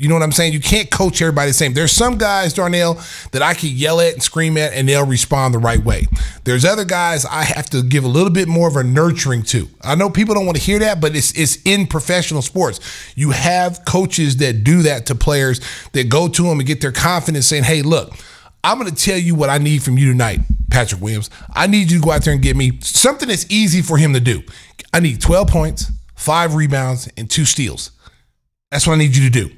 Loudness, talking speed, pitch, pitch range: -15 LUFS, 250 wpm, 150 Hz, 130-170 Hz